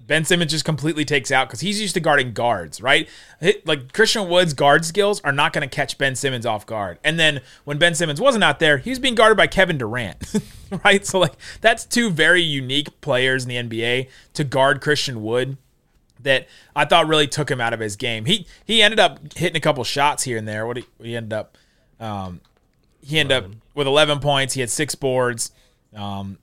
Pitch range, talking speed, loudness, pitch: 125-170 Hz, 220 wpm, -19 LUFS, 145 Hz